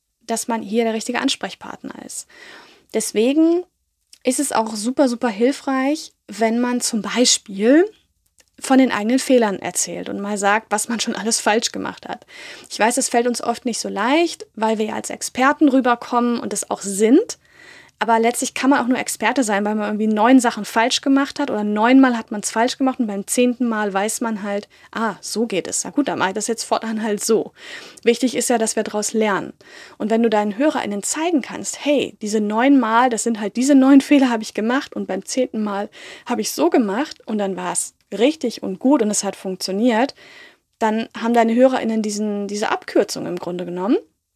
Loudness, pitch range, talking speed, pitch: -19 LUFS, 215-260 Hz, 205 wpm, 230 Hz